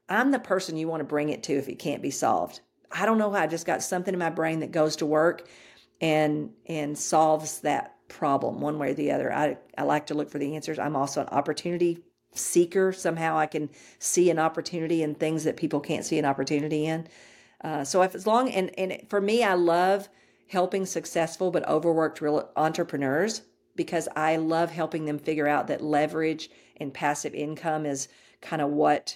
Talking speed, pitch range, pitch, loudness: 205 wpm, 150-175 Hz, 160 Hz, -27 LUFS